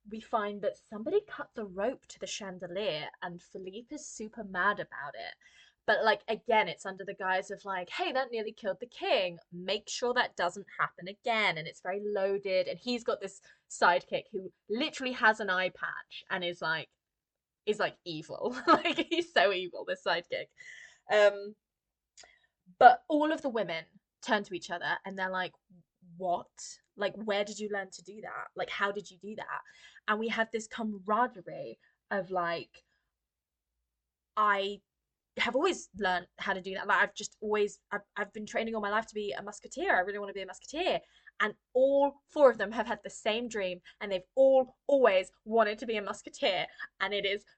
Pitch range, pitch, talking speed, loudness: 185-225 Hz, 205 Hz, 190 wpm, -31 LUFS